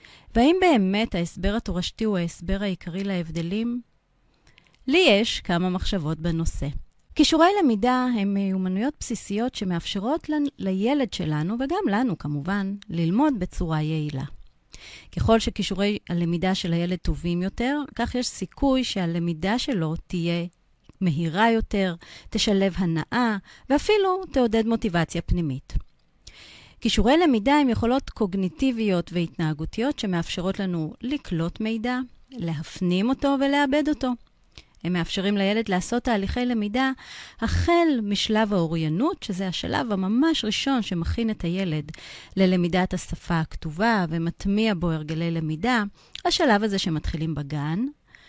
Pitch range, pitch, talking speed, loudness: 170-245 Hz, 200 Hz, 110 wpm, -24 LUFS